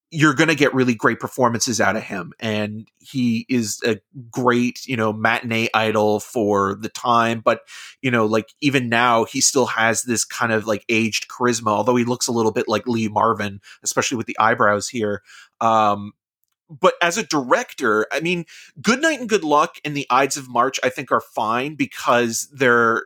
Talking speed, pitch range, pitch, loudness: 195 wpm, 110-135 Hz, 120 Hz, -19 LUFS